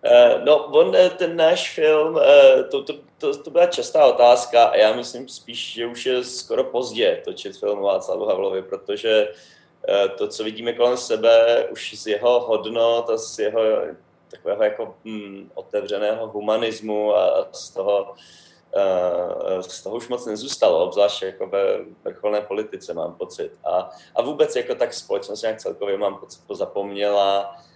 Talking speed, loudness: 150 wpm, -20 LUFS